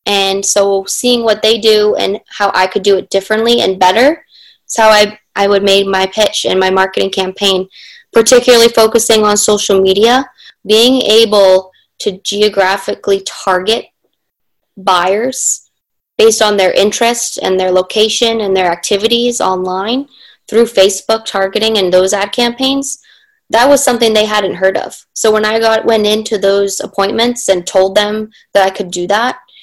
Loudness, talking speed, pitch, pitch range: -11 LUFS, 160 wpm, 210 Hz, 195-230 Hz